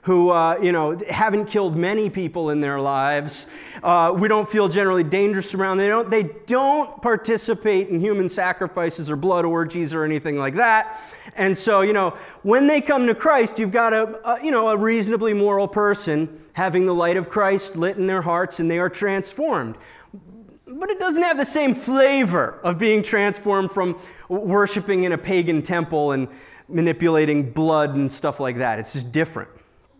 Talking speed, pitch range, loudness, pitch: 185 wpm, 165-215 Hz, -20 LUFS, 190 Hz